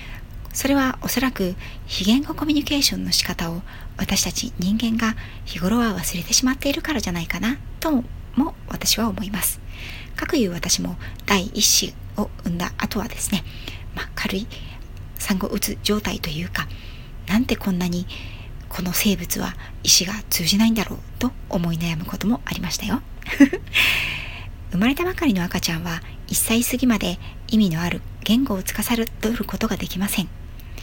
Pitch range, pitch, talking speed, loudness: 165-235 Hz, 200 Hz, 315 characters per minute, -22 LUFS